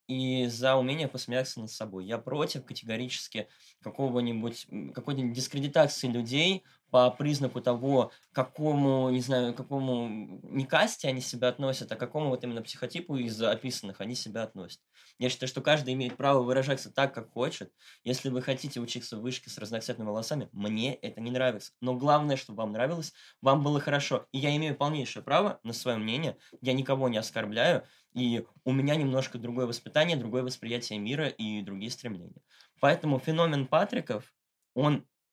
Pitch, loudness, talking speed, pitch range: 130 Hz, -30 LUFS, 165 wpm, 120-135 Hz